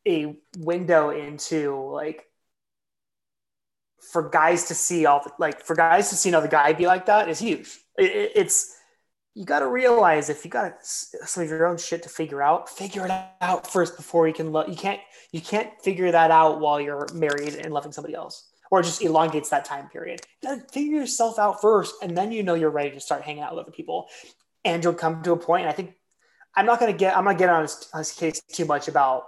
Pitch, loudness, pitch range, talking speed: 170 Hz, -23 LUFS, 155-195 Hz, 230 wpm